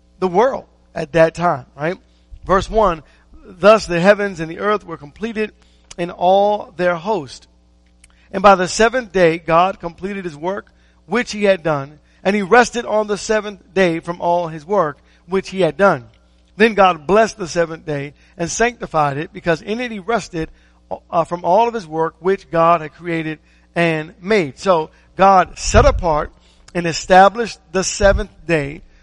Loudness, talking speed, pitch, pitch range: -17 LUFS, 170 wpm, 175 Hz, 160-200 Hz